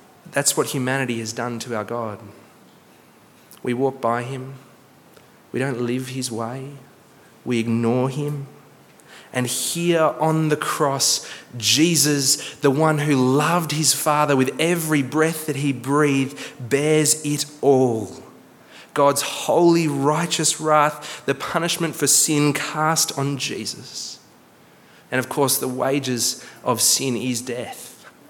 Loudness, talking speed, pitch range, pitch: -20 LUFS, 130 wpm, 125-155 Hz, 140 Hz